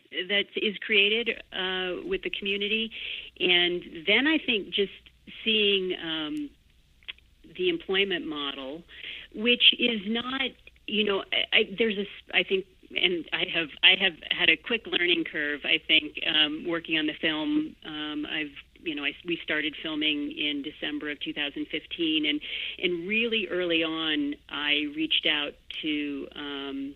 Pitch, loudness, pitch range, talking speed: 185 Hz, -26 LUFS, 155-240 Hz, 150 wpm